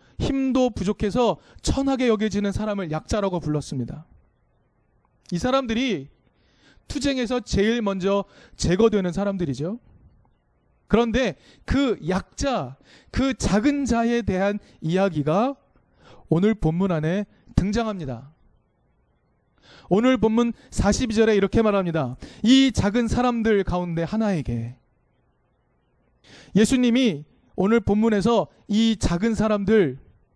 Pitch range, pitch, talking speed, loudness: 175-235 Hz, 205 Hz, 230 characters per minute, -23 LUFS